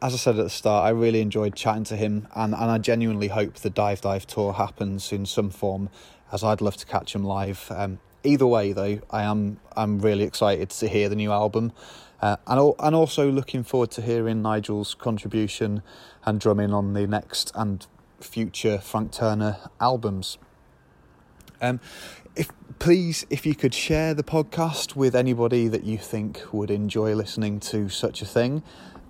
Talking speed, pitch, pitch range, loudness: 180 wpm, 110 Hz, 100-115 Hz, -25 LUFS